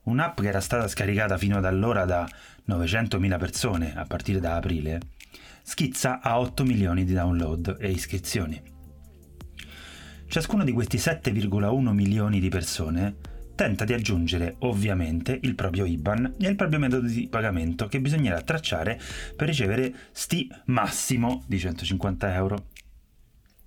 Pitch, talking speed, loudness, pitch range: 100 Hz, 135 wpm, -26 LUFS, 85-120 Hz